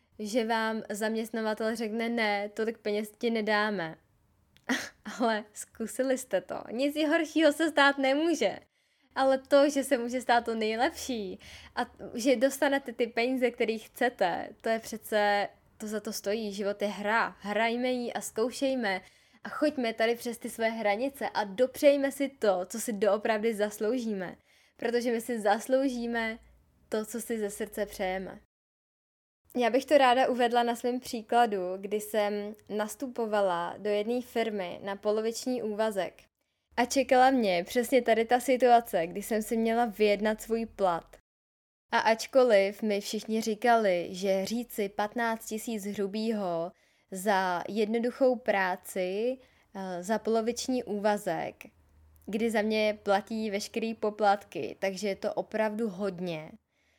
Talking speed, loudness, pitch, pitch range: 135 wpm, -29 LUFS, 220 Hz, 205-240 Hz